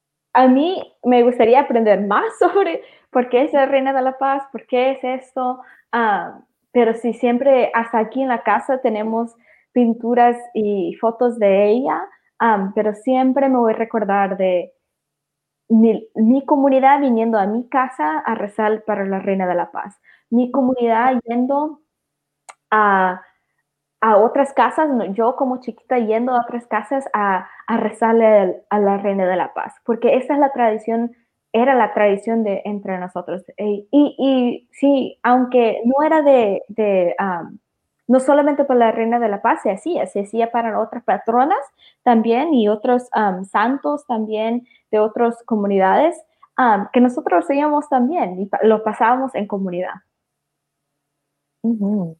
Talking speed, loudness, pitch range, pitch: 155 wpm, -17 LUFS, 205-260 Hz, 230 Hz